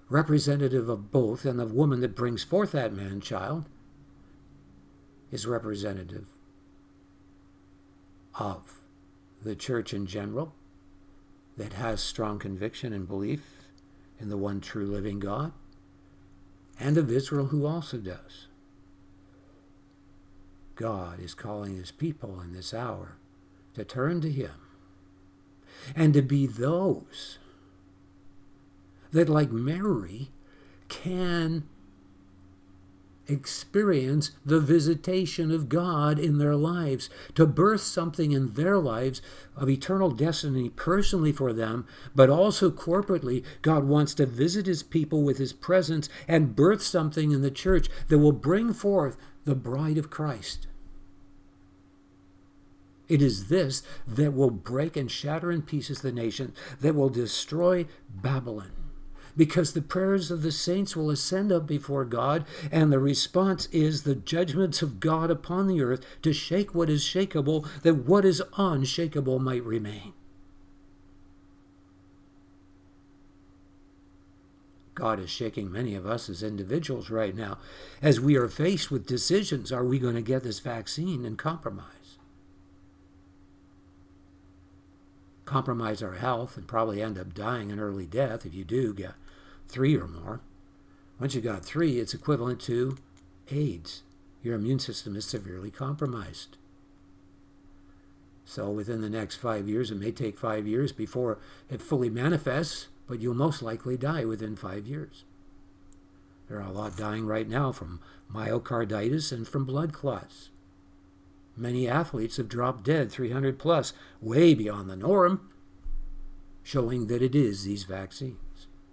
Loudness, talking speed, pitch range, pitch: -28 LUFS, 130 wpm, 95-145 Hz, 115 Hz